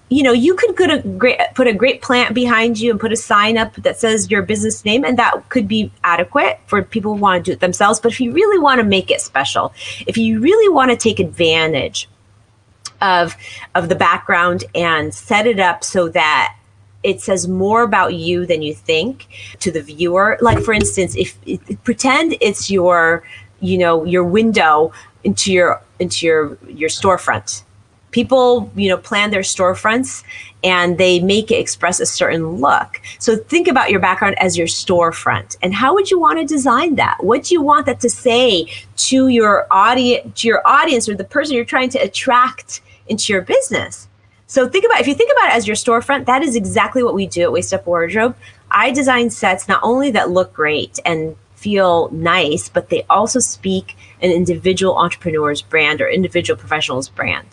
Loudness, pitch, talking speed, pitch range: -15 LUFS, 200 Hz, 195 wpm, 175-245 Hz